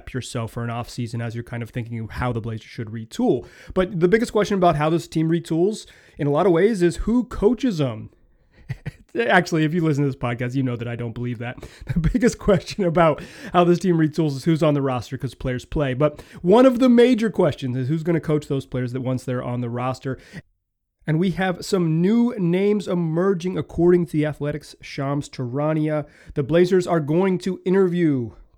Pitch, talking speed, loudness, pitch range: 155 Hz, 210 wpm, -21 LUFS, 125-180 Hz